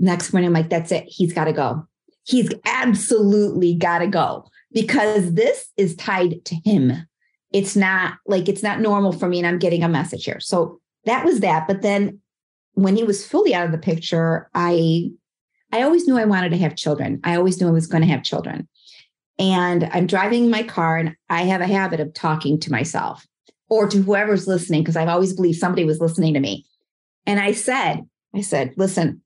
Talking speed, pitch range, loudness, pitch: 205 wpm, 165-205 Hz, -19 LUFS, 180 Hz